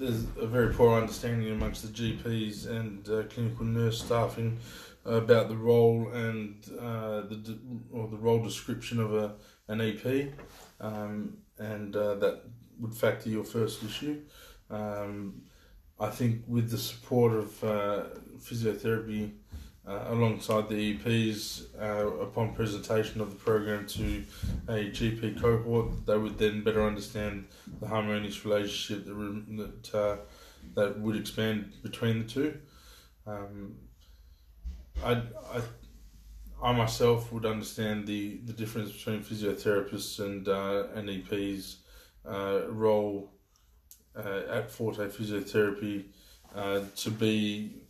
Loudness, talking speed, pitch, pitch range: -32 LUFS, 125 wpm, 110 Hz, 105-115 Hz